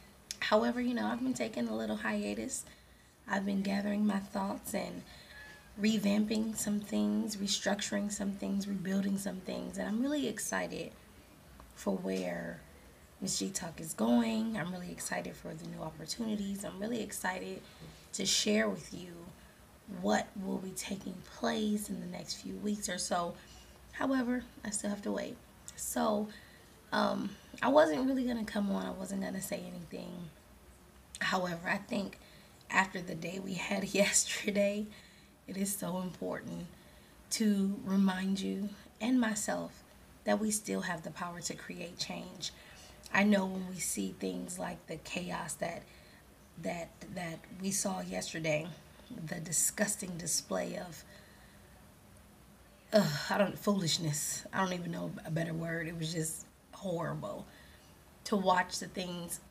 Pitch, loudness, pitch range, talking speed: 195 Hz, -35 LUFS, 165-210 Hz, 150 wpm